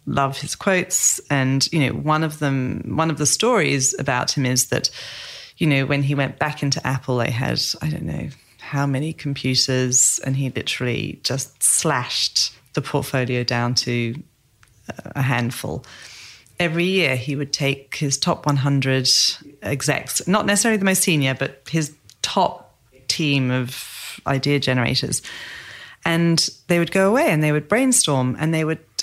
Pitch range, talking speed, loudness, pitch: 130-155 Hz, 160 wpm, -20 LUFS, 140 Hz